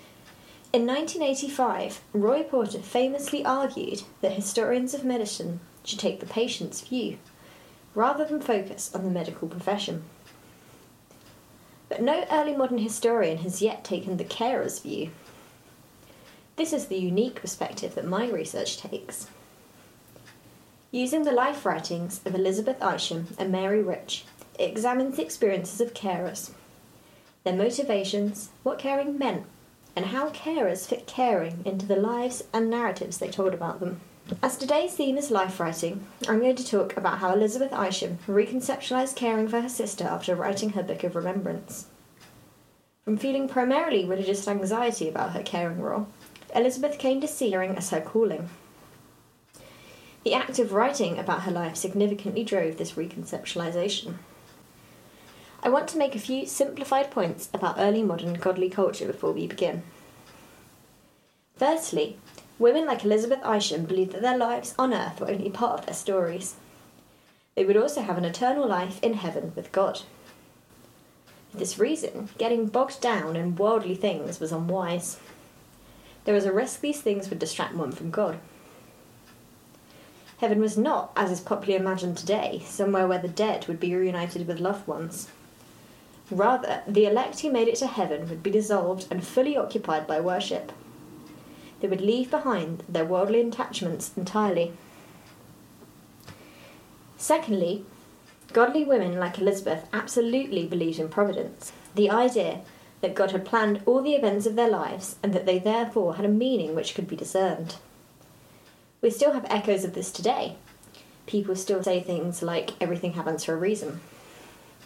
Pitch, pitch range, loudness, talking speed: 205 Hz, 185-245 Hz, -27 LUFS, 150 wpm